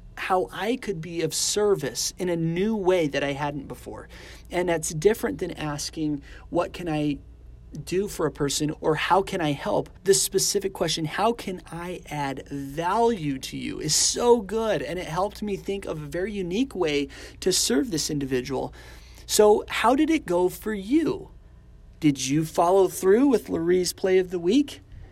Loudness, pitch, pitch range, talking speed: -25 LUFS, 175 Hz, 150-200 Hz, 180 wpm